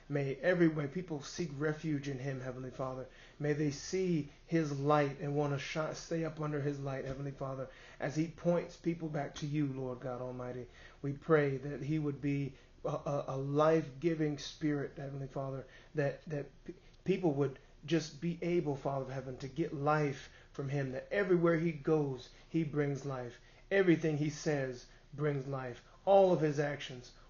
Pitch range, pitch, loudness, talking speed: 135-155 Hz, 145 Hz, -36 LUFS, 175 wpm